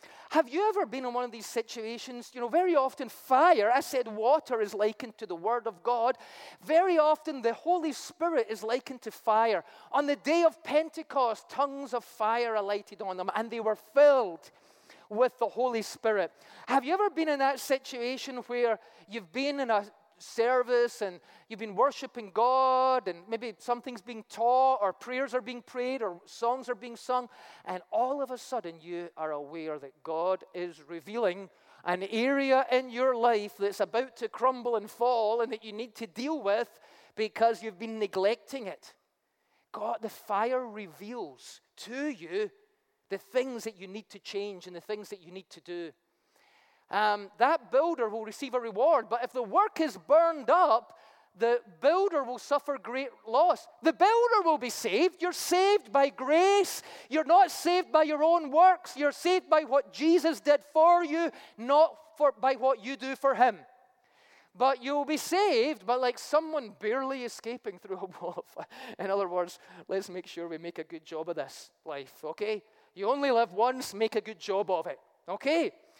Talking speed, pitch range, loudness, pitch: 185 wpm, 215-285 Hz, -29 LUFS, 245 Hz